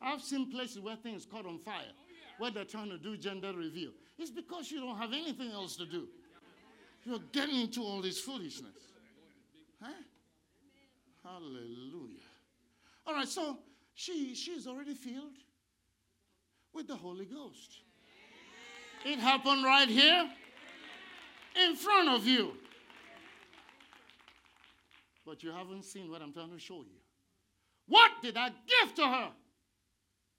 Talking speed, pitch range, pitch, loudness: 130 wpm, 195-290 Hz, 255 Hz, -31 LUFS